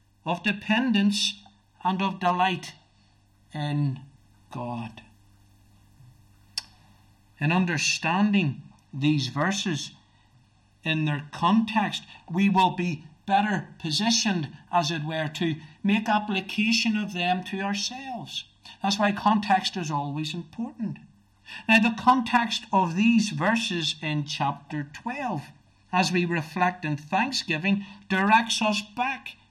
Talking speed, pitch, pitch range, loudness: 105 wpm, 175 Hz, 145-205 Hz, -25 LUFS